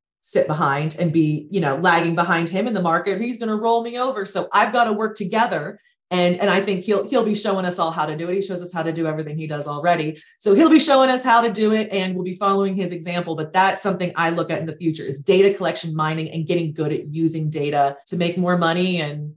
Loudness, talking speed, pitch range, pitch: -20 LUFS, 270 wpm, 160-200 Hz, 180 Hz